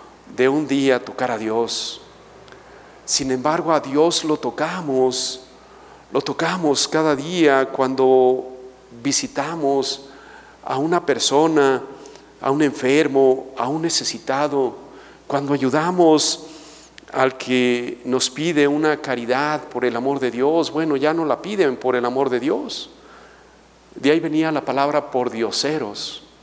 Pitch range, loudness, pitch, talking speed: 130-155 Hz, -20 LUFS, 135 Hz, 130 wpm